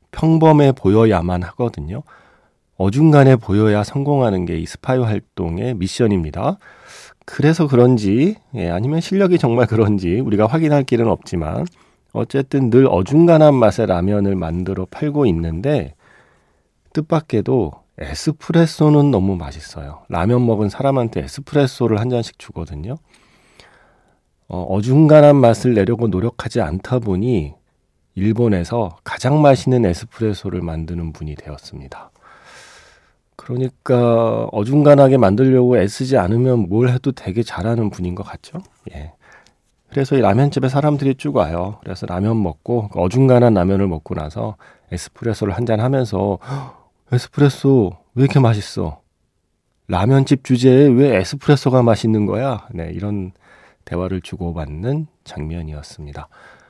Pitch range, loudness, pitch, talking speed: 95-135 Hz, -16 LUFS, 115 Hz, 310 characters per minute